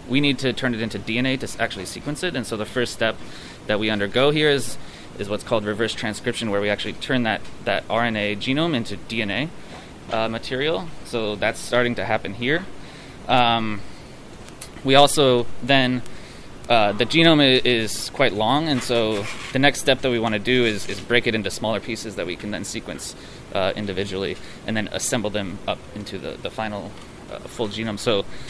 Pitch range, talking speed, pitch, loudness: 105-130 Hz, 195 wpm, 115 Hz, -22 LUFS